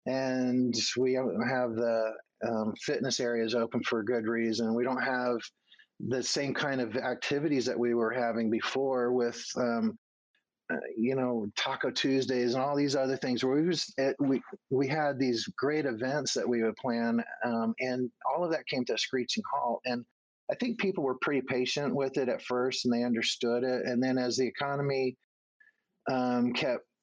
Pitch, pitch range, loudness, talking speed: 125 Hz, 120-135 Hz, -31 LUFS, 185 wpm